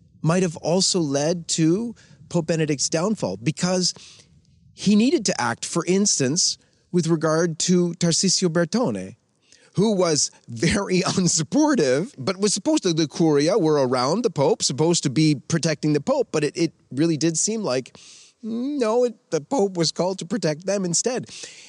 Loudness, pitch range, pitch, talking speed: -21 LUFS, 155-200 Hz, 170 Hz, 160 wpm